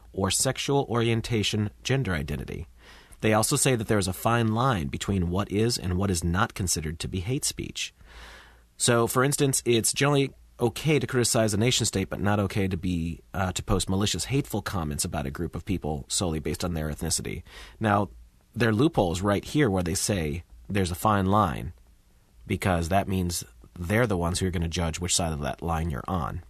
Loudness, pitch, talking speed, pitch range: -26 LUFS, 95 Hz, 200 wpm, 85-110 Hz